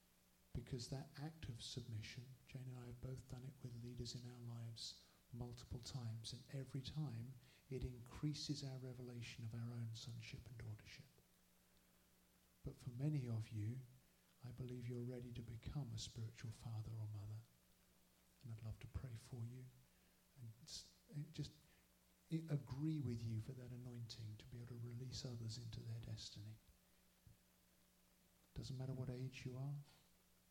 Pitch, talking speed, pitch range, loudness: 120 Hz, 155 wpm, 110-130 Hz, -52 LUFS